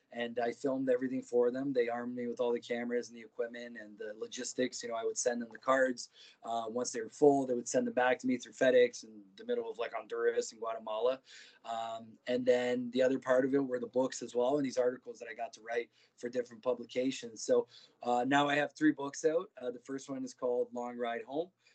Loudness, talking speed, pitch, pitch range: -34 LUFS, 250 wpm, 125 Hz, 120-140 Hz